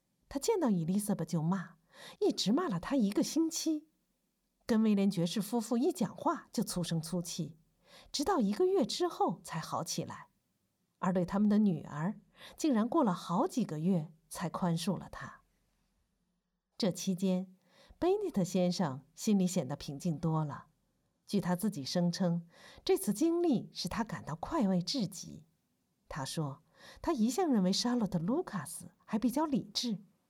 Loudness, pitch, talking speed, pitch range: -33 LUFS, 190 Hz, 230 characters per minute, 180-240 Hz